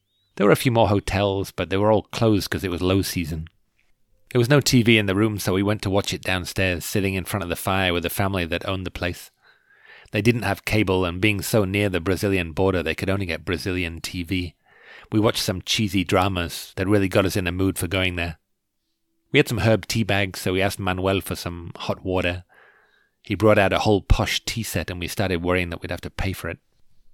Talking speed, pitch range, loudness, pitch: 240 wpm, 90-105 Hz, -22 LUFS, 95 Hz